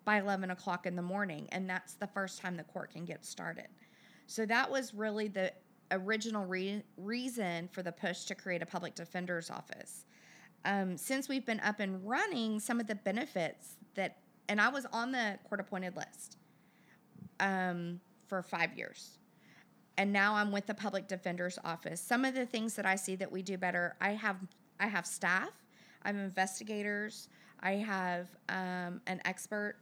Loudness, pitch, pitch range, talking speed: -37 LUFS, 195 Hz, 185-215 Hz, 175 wpm